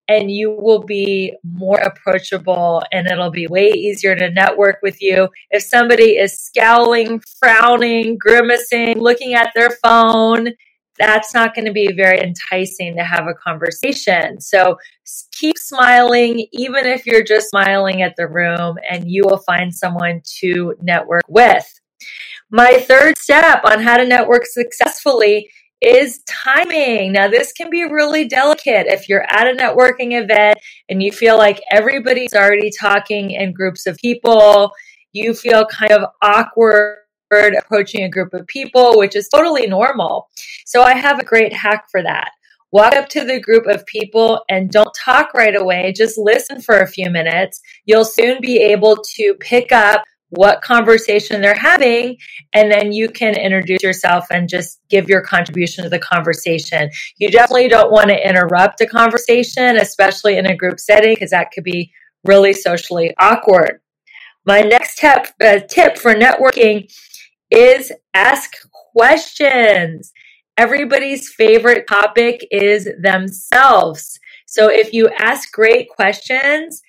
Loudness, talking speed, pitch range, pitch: -12 LUFS, 150 wpm, 190-240 Hz, 215 Hz